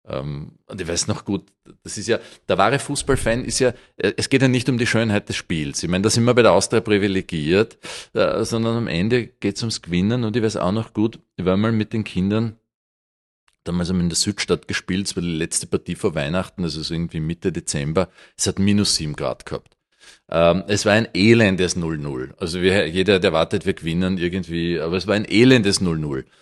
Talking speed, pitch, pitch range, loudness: 210 wpm, 100 Hz, 85-115 Hz, -20 LUFS